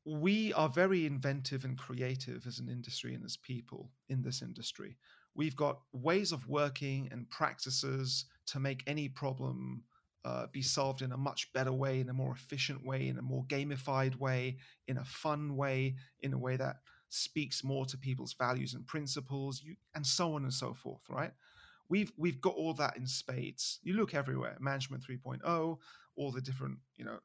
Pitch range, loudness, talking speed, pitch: 130-145 Hz, -37 LUFS, 185 wpm, 135 Hz